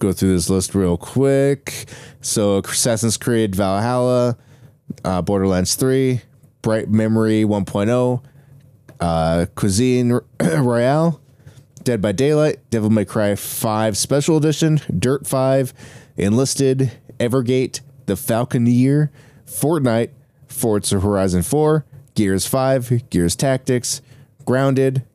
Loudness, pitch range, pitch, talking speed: -18 LUFS, 110-135 Hz, 125 Hz, 105 wpm